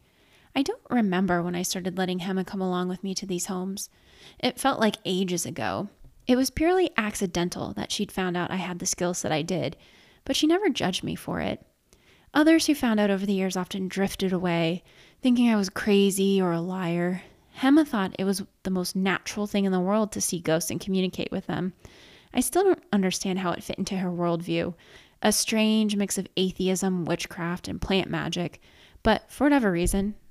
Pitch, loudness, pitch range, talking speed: 190 Hz, -26 LUFS, 180-215 Hz, 200 wpm